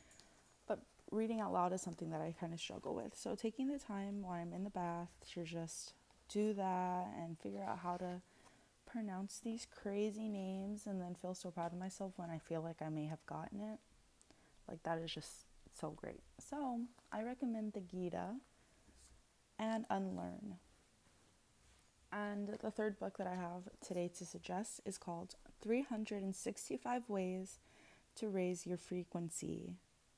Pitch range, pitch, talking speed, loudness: 165-210 Hz, 185 Hz, 160 wpm, -45 LUFS